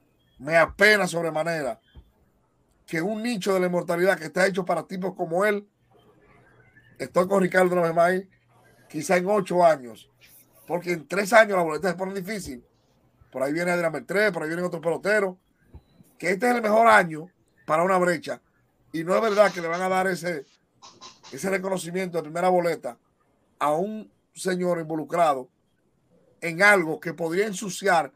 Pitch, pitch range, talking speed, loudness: 180 Hz, 165-195 Hz, 160 wpm, -24 LUFS